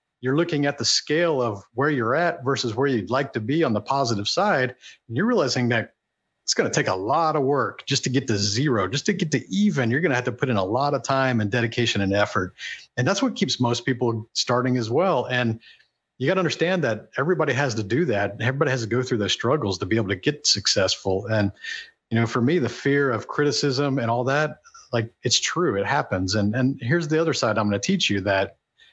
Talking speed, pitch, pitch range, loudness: 245 wpm, 125 Hz, 115-145 Hz, -23 LUFS